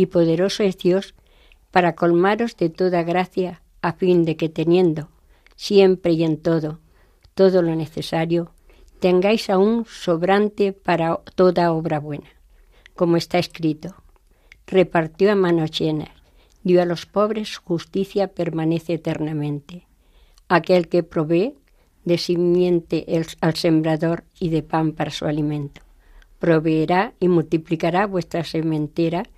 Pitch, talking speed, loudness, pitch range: 170 Hz, 125 wpm, -20 LUFS, 160-185 Hz